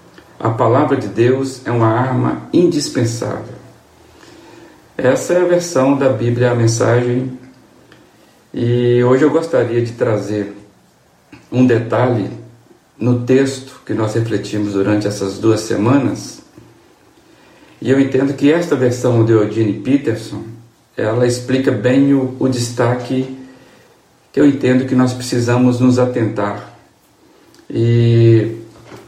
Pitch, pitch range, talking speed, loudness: 120 Hz, 110-130 Hz, 120 wpm, -15 LUFS